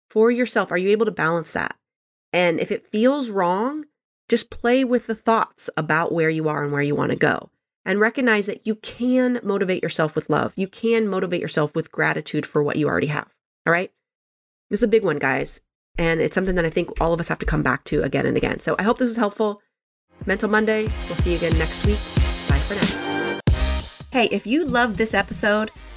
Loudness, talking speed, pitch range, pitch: -22 LUFS, 220 wpm, 170-235 Hz, 210 Hz